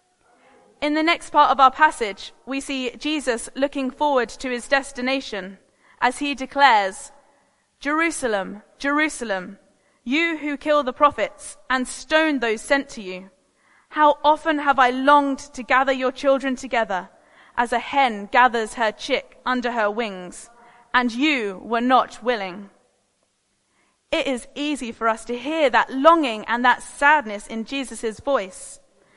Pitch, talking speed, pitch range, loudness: 260 Hz, 145 wpm, 235-285 Hz, -21 LUFS